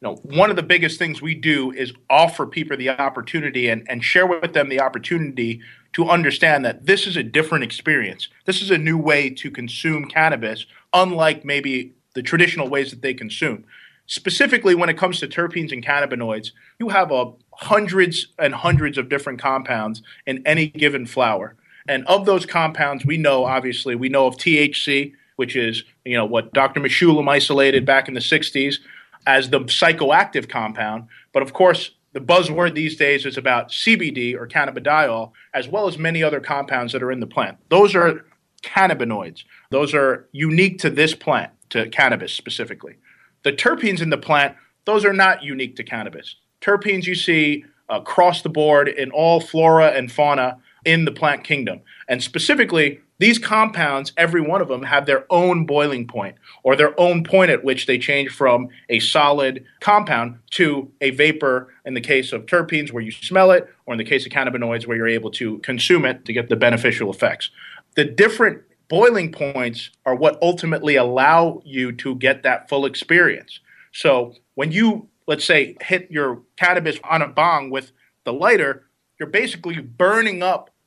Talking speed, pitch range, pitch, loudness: 180 wpm, 130-170 Hz, 145 Hz, -18 LUFS